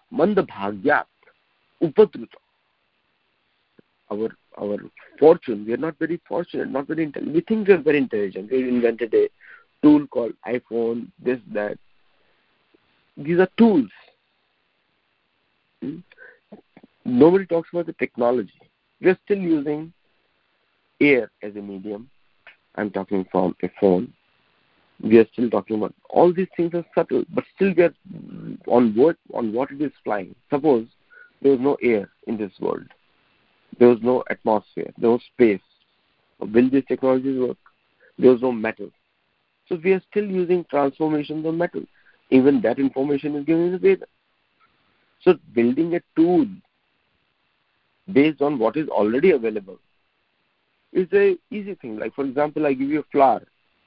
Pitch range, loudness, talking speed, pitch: 120-180 Hz, -21 LUFS, 145 wpm, 145 Hz